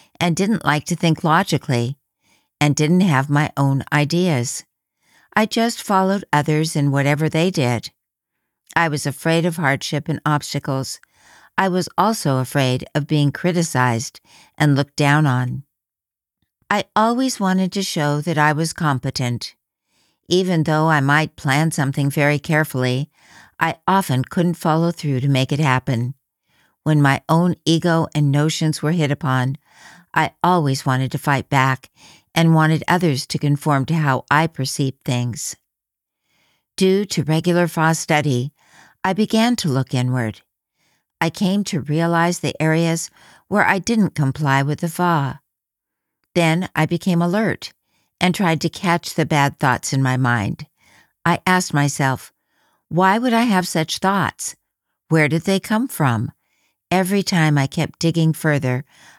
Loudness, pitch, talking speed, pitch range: -19 LUFS, 155 Hz, 150 wpm, 140-170 Hz